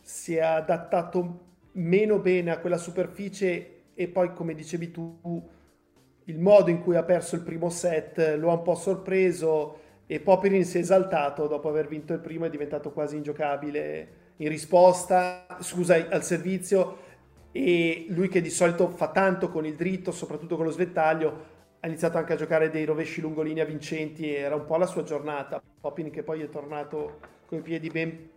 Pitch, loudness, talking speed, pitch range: 165 Hz, -27 LUFS, 180 wpm, 155-180 Hz